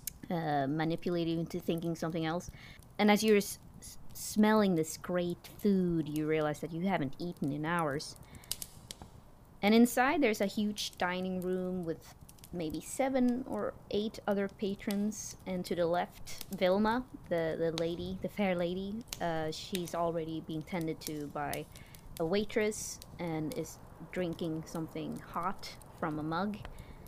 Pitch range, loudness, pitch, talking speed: 160-200 Hz, -34 LUFS, 175 Hz, 140 wpm